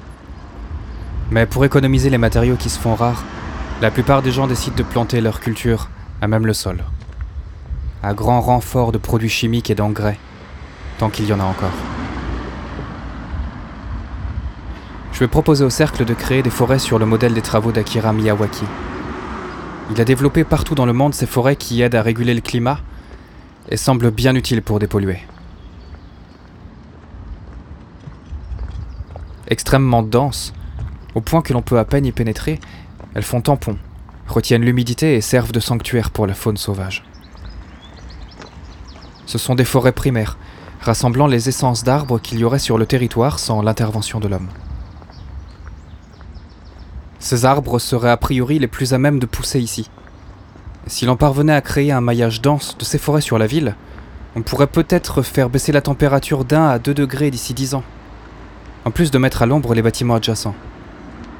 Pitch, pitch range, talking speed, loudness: 110 Hz, 90-125 Hz, 160 wpm, -17 LUFS